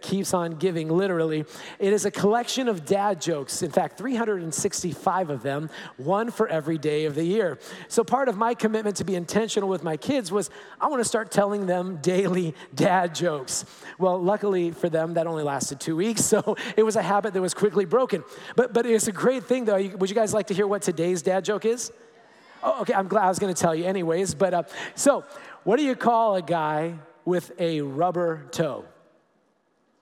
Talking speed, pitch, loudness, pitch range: 210 wpm, 190 Hz, -25 LUFS, 170-215 Hz